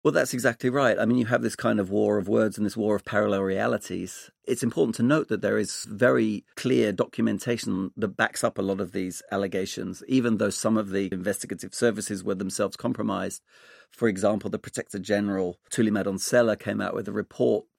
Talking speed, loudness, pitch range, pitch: 200 wpm, -26 LUFS, 100-115 Hz, 105 Hz